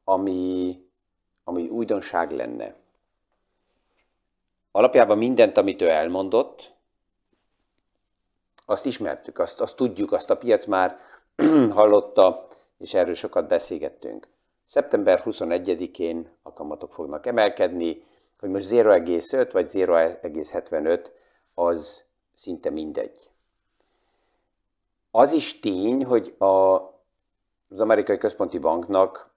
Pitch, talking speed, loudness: 100 Hz, 95 wpm, -22 LUFS